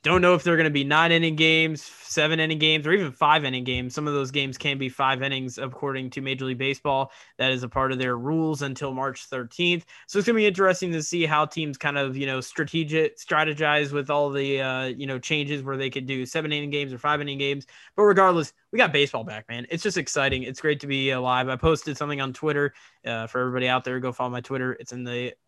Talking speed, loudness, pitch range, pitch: 250 wpm, -24 LUFS, 130-155 Hz, 140 Hz